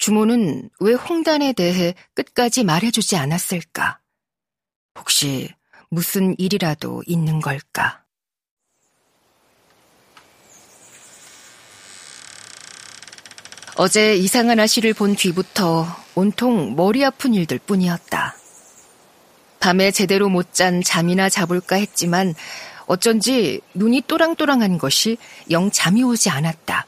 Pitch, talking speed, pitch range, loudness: 190 Hz, 205 characters per minute, 170-225 Hz, -18 LUFS